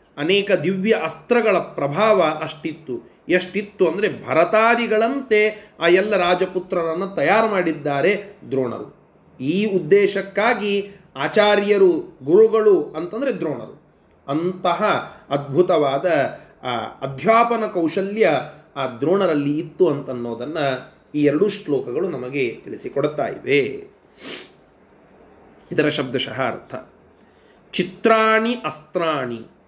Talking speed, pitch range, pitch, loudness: 80 wpm, 155-215 Hz, 190 Hz, -20 LUFS